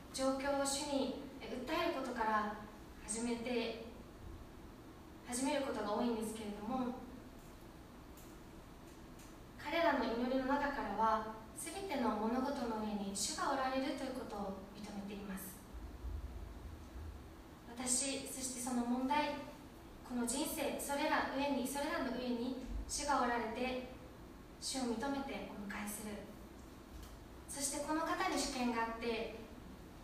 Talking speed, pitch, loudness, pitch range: 235 characters per minute, 250 Hz, -39 LUFS, 215-280 Hz